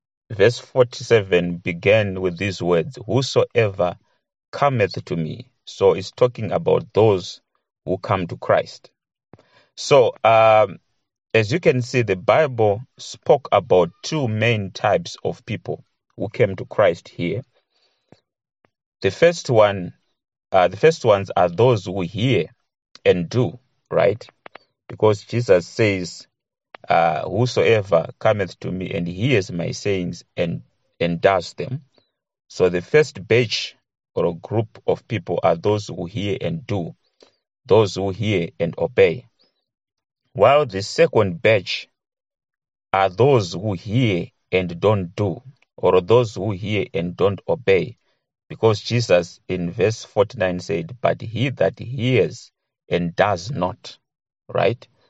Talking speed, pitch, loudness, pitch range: 130 wpm, 110 Hz, -20 LUFS, 95-130 Hz